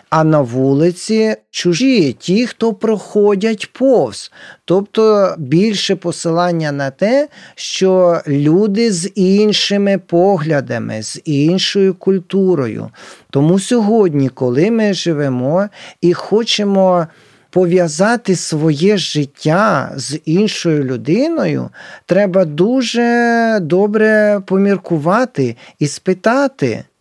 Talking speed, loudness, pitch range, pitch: 90 wpm, -14 LUFS, 160-210 Hz, 185 Hz